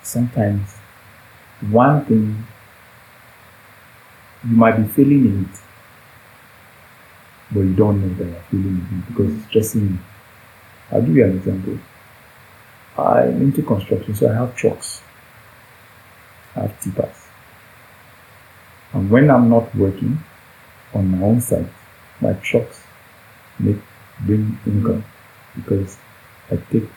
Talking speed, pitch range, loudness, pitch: 120 wpm, 100-120 Hz, -18 LUFS, 110 Hz